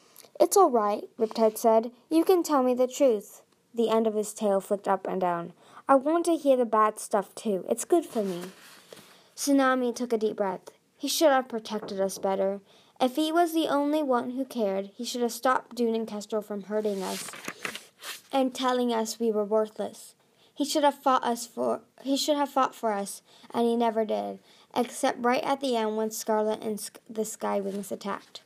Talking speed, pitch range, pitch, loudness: 200 wpm, 215-265 Hz, 230 Hz, -27 LUFS